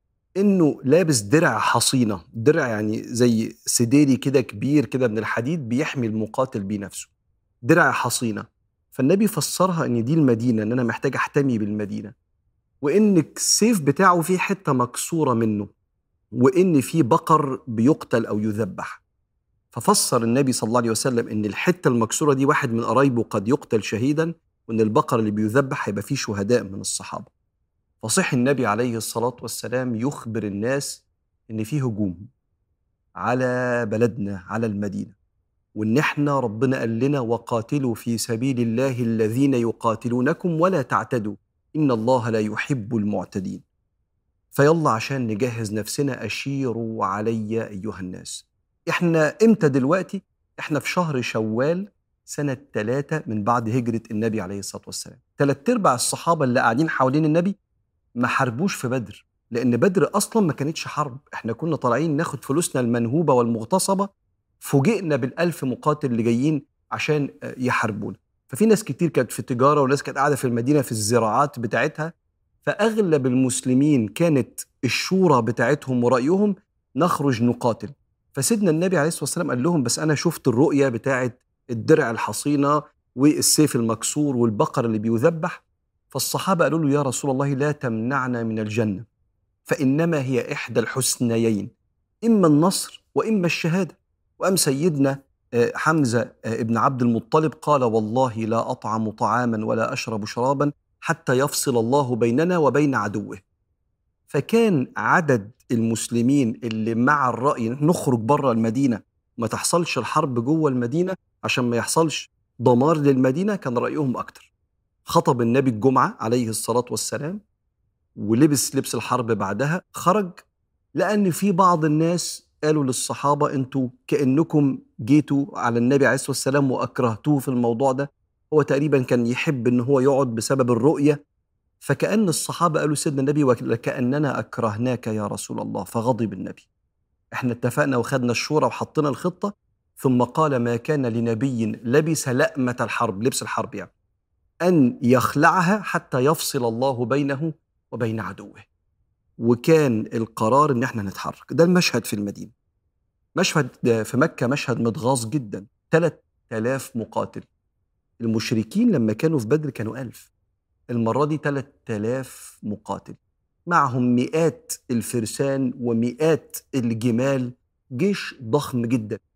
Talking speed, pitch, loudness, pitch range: 130 wpm, 125 Hz, -22 LUFS, 115-150 Hz